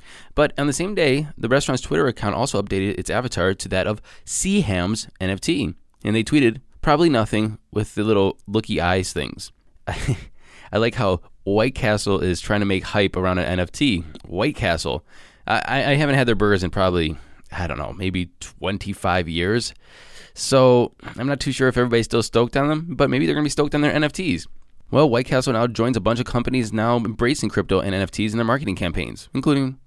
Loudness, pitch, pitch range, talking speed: -21 LUFS, 110 Hz, 95-130 Hz, 195 wpm